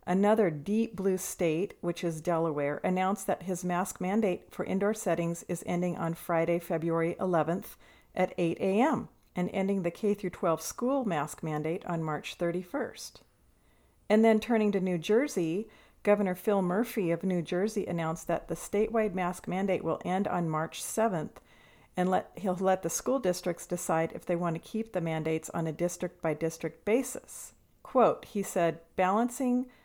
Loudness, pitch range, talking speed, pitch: -31 LUFS, 170-205 Hz, 160 wpm, 180 Hz